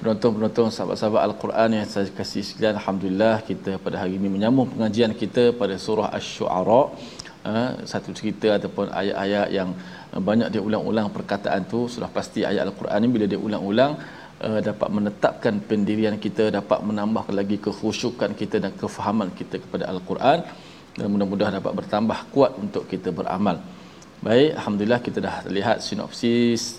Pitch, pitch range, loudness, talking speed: 105 Hz, 100-110 Hz, -23 LUFS, 145 wpm